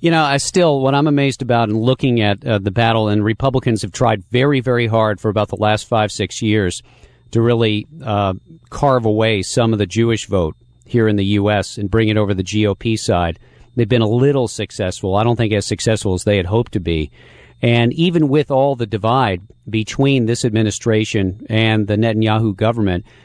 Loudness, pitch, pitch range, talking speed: -17 LUFS, 110 Hz, 105-125 Hz, 200 wpm